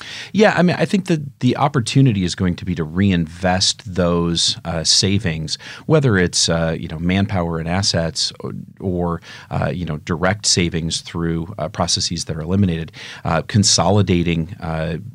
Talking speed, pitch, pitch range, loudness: 160 wpm, 90 Hz, 85-110 Hz, -18 LUFS